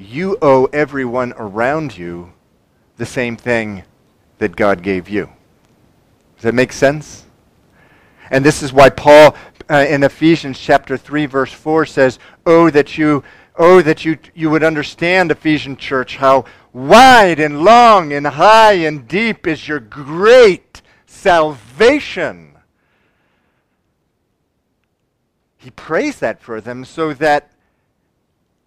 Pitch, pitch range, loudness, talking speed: 145 Hz, 125-160 Hz, -12 LUFS, 125 wpm